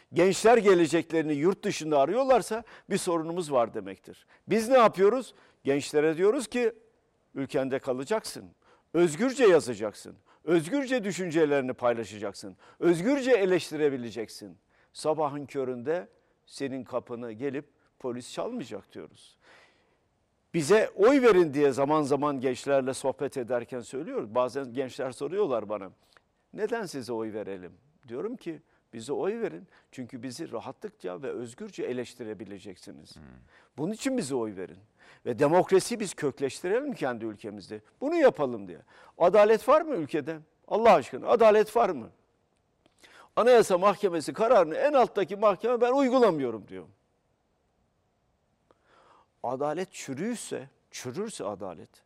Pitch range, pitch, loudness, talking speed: 125-210 Hz, 155 Hz, -27 LUFS, 110 wpm